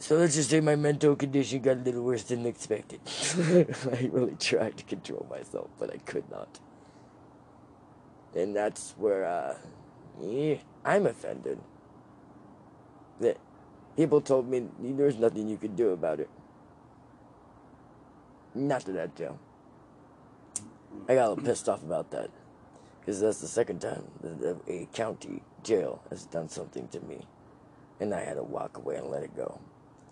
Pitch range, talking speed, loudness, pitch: 125-150 Hz, 150 wpm, -30 LUFS, 135 Hz